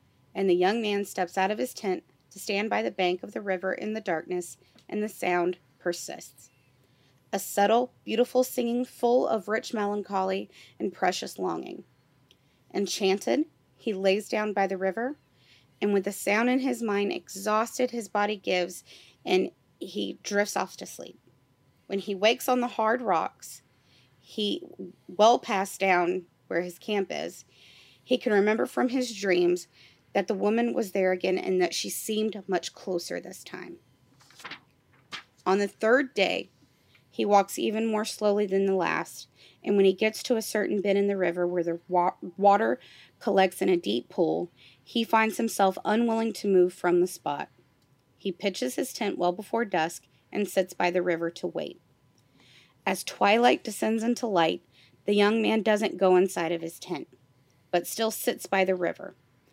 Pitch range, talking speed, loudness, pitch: 170-215 Hz, 170 wpm, -27 LUFS, 190 Hz